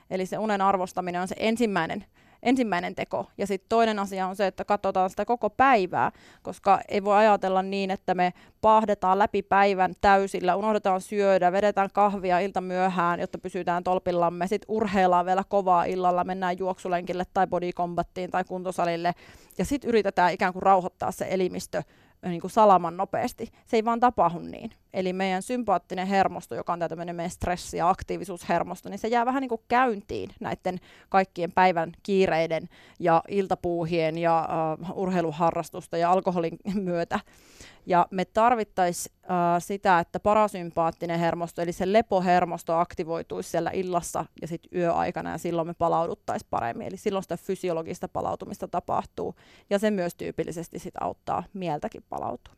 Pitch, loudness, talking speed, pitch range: 185 Hz, -26 LUFS, 155 wpm, 175-200 Hz